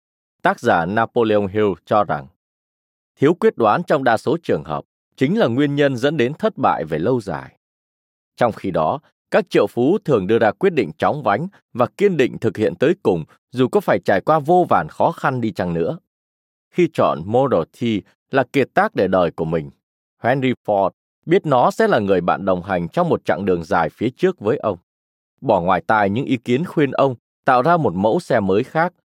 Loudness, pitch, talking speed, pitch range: -19 LUFS, 115 Hz, 210 wpm, 90-145 Hz